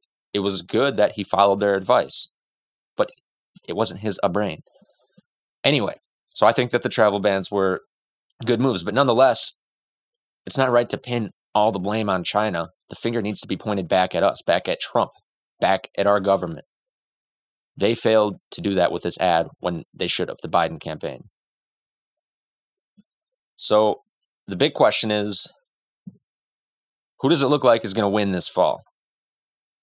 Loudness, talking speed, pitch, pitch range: -21 LUFS, 170 wpm, 105 Hz, 100-120 Hz